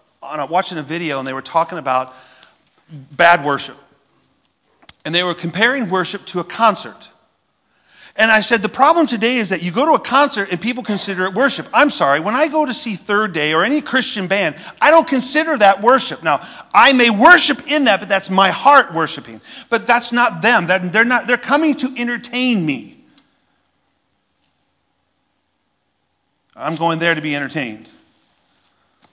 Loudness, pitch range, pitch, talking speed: -15 LUFS, 165-250 Hz, 205 Hz, 175 wpm